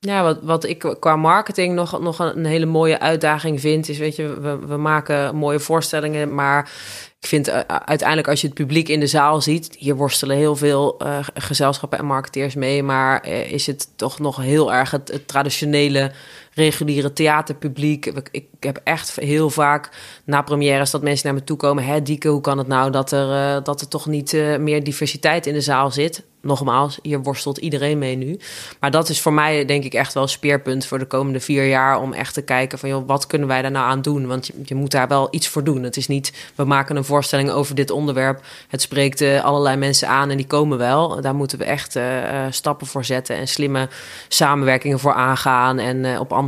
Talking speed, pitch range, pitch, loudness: 210 wpm, 135-150 Hz, 145 Hz, -19 LUFS